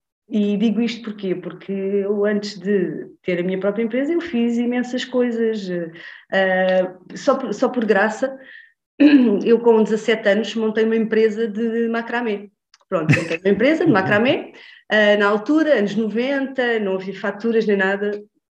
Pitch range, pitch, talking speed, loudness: 200-240 Hz, 220 Hz, 155 wpm, -19 LUFS